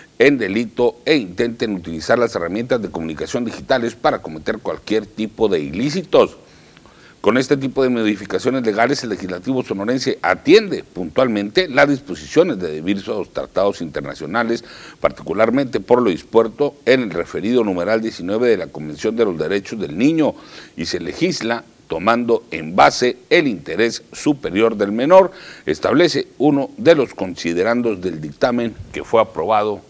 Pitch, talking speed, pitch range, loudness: 115 Hz, 145 wpm, 105-135 Hz, -18 LUFS